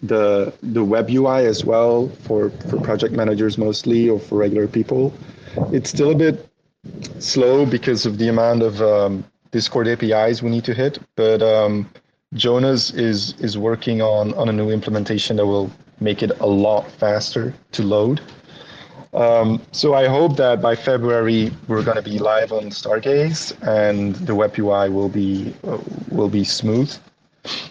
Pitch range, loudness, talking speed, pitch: 105-125 Hz, -18 LUFS, 165 wpm, 110 Hz